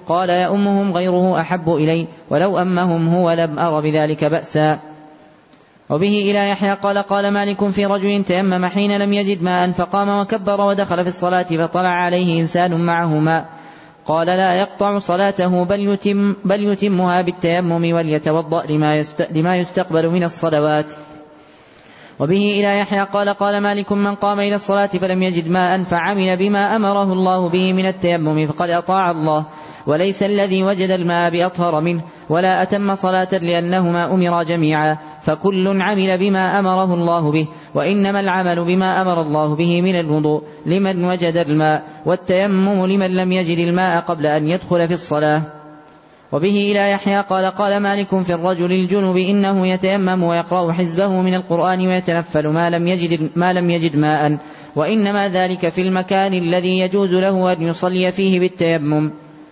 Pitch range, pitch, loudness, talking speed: 165-195 Hz, 180 Hz, -17 LUFS, 145 wpm